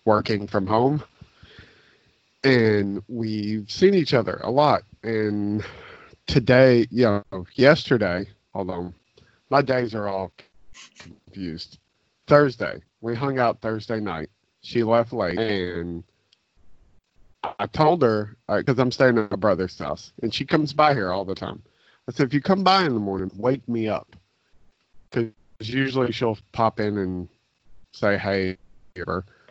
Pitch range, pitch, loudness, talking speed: 95-125 Hz, 110 Hz, -23 LUFS, 140 wpm